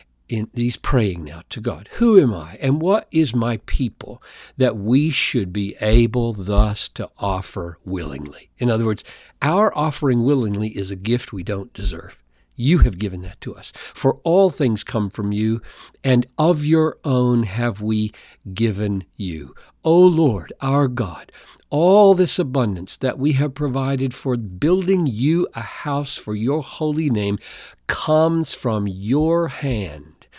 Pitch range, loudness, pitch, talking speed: 100-145 Hz, -20 LUFS, 120 Hz, 160 wpm